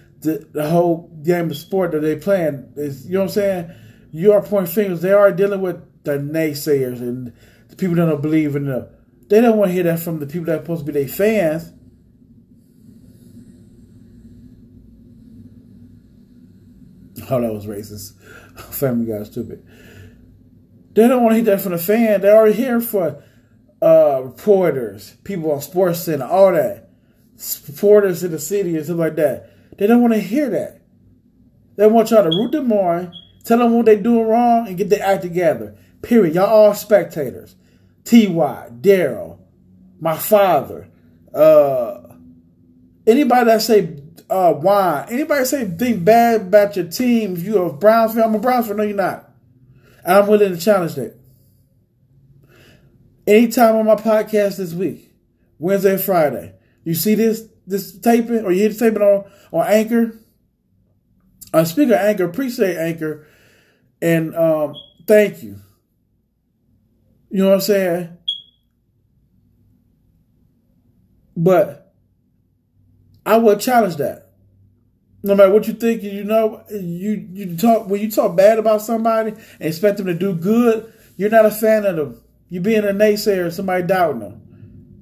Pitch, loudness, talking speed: 180 Hz, -16 LUFS, 160 wpm